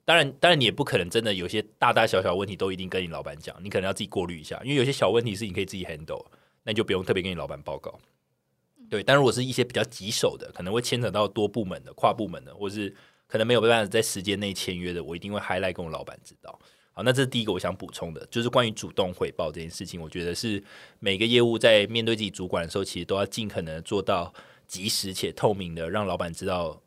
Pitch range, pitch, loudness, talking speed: 90-115 Hz, 100 Hz, -26 LUFS, 420 characters per minute